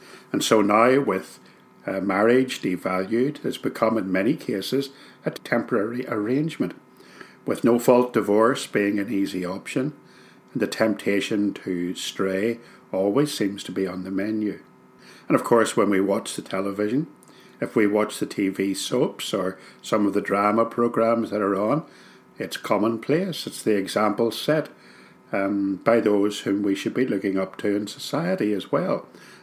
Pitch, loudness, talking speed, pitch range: 100 Hz, -24 LUFS, 155 wpm, 95-115 Hz